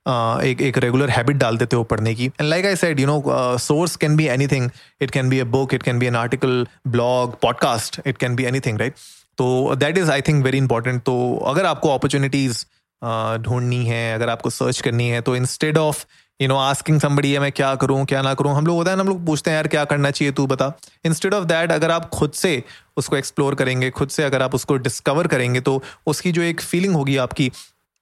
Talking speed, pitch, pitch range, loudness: 235 wpm, 135 Hz, 125-150 Hz, -19 LUFS